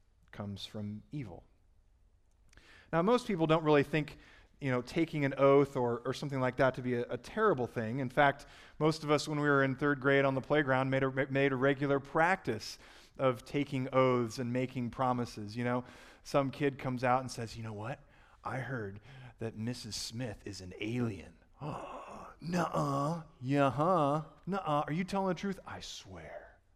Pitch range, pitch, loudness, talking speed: 115-145 Hz, 130 Hz, -33 LUFS, 180 wpm